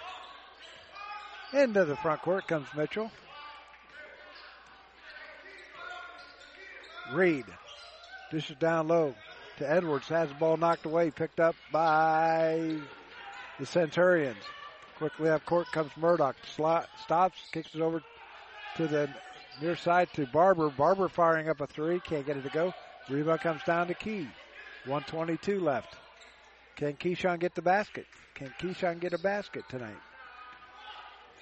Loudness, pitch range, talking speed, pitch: -30 LUFS, 155-210 Hz, 125 wpm, 170 Hz